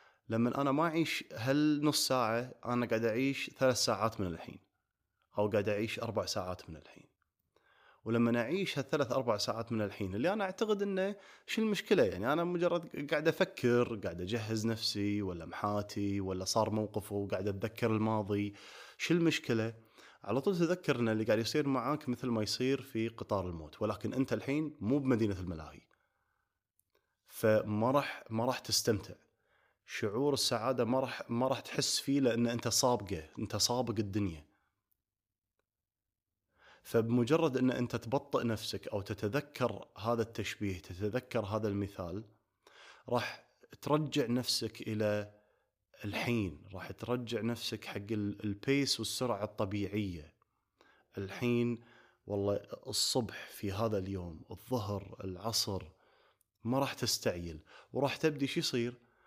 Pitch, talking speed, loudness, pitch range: 115 Hz, 130 wpm, -34 LUFS, 105-130 Hz